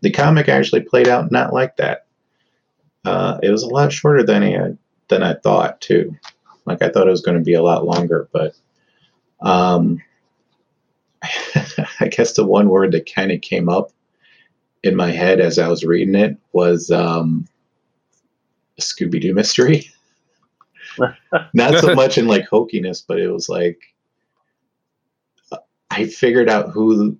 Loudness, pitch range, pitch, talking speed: -16 LUFS, 85-105 Hz, 90 Hz, 155 wpm